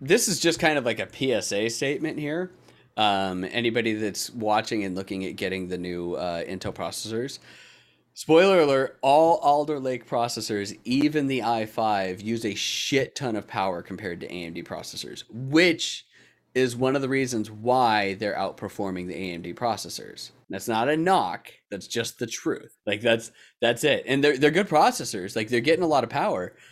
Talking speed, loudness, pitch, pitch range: 175 wpm, -25 LUFS, 115 Hz, 100-140 Hz